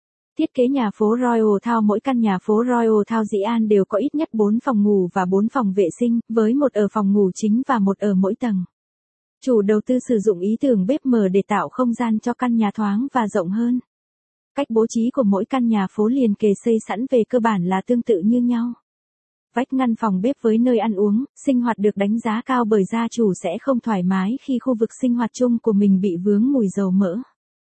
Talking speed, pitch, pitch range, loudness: 240 wpm, 225 Hz, 205-245 Hz, -19 LUFS